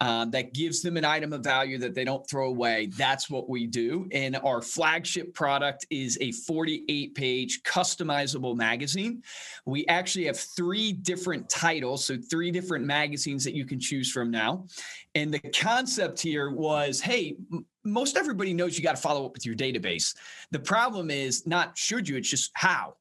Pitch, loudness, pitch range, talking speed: 145 Hz, -28 LUFS, 130-175 Hz, 185 wpm